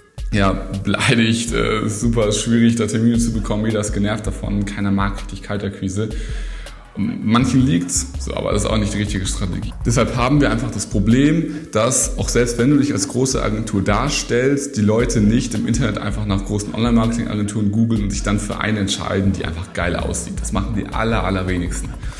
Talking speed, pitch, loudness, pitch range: 185 wpm, 105 Hz, -19 LUFS, 100-115 Hz